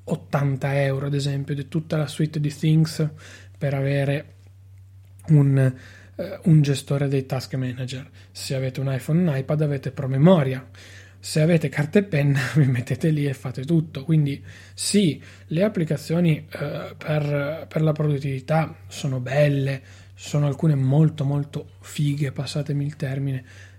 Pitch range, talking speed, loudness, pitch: 130-150 Hz, 145 wpm, -23 LUFS, 140 Hz